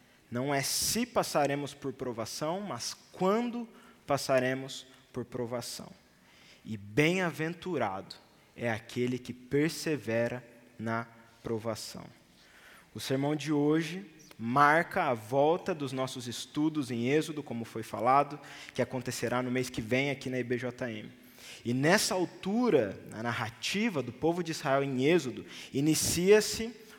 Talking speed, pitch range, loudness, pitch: 120 wpm, 120-160 Hz, -31 LUFS, 135 Hz